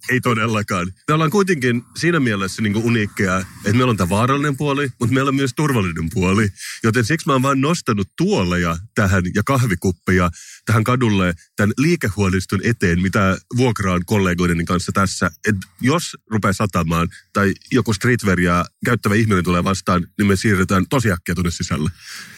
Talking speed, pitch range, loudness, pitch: 155 wpm, 95-125 Hz, -18 LUFS, 105 Hz